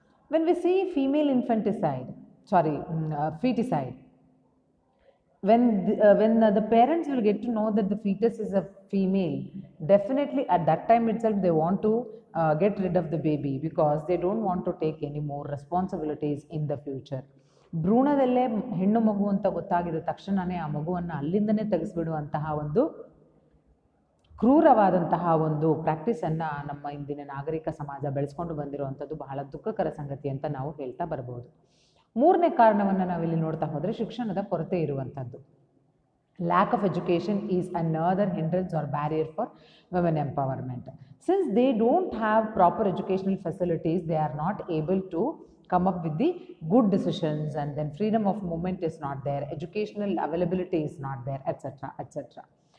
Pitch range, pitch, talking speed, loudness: 155-210 Hz, 175 Hz, 145 wpm, -27 LUFS